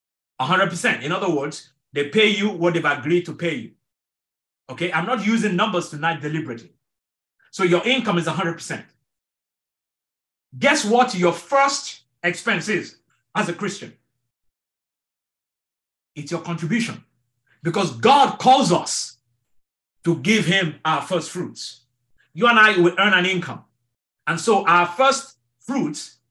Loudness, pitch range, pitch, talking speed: -20 LUFS, 145-205 Hz, 175 Hz, 135 wpm